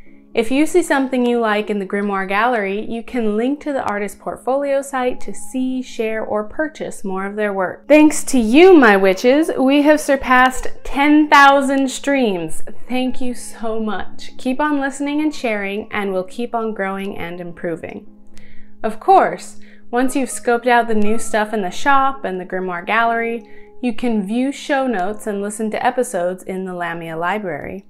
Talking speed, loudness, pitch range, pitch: 175 wpm, -17 LUFS, 200-265 Hz, 230 Hz